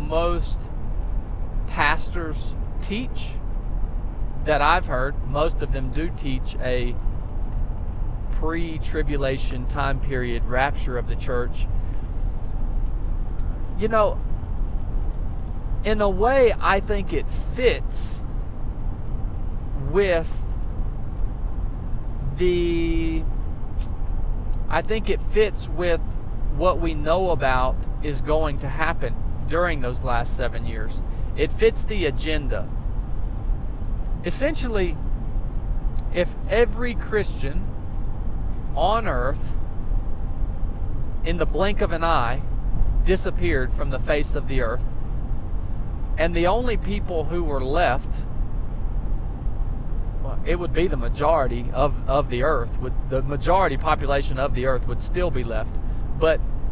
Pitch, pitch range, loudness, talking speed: 120 Hz, 95-145 Hz, -26 LUFS, 105 wpm